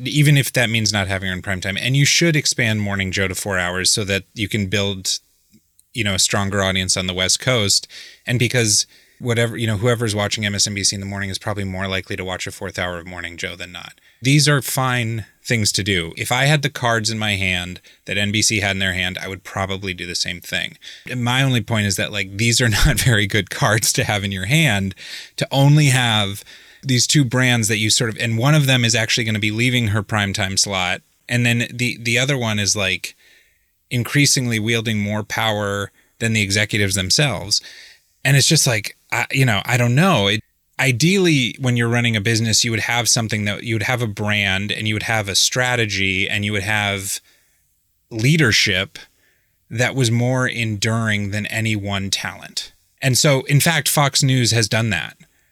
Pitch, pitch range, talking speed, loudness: 110 Hz, 100-125 Hz, 215 wpm, -18 LUFS